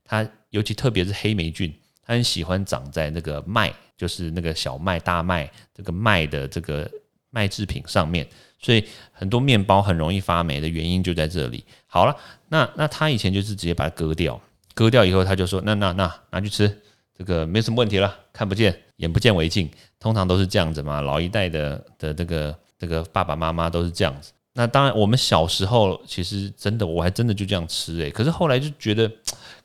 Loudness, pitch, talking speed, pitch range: -22 LUFS, 95 Hz, 310 characters per minute, 85-110 Hz